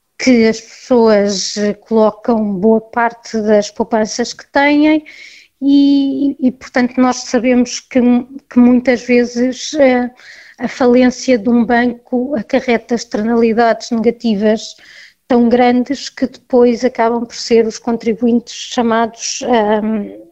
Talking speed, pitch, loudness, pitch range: 115 wpm, 240 Hz, -14 LUFS, 225-255 Hz